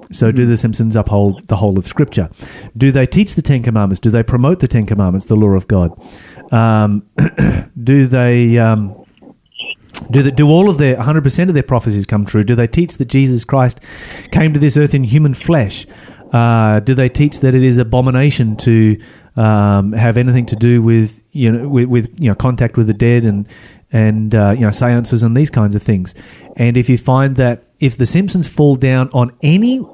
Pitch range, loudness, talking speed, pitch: 110-135 Hz, -12 LUFS, 210 wpm, 120 Hz